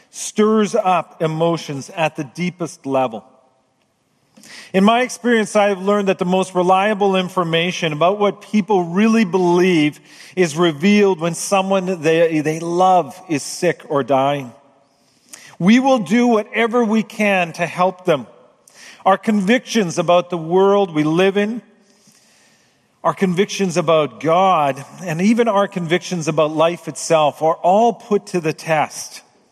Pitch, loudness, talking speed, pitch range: 180 Hz, -17 LUFS, 140 wpm, 160-205 Hz